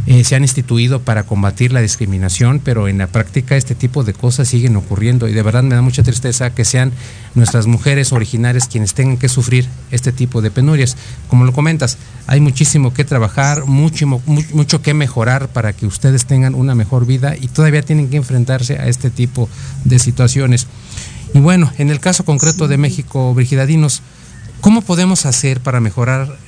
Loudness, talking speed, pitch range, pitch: -13 LUFS, 185 wpm, 120-140 Hz, 130 Hz